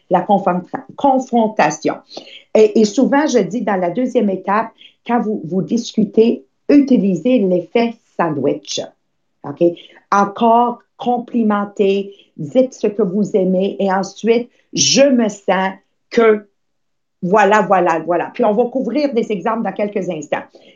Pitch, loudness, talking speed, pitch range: 215 Hz, -16 LUFS, 125 wpm, 195-240 Hz